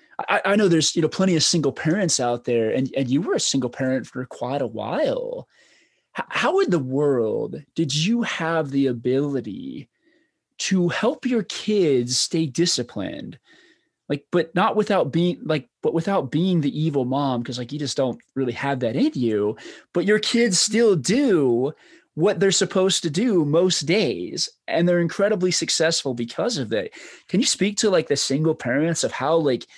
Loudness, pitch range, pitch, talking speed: -22 LUFS, 140-200 Hz, 165 Hz, 180 wpm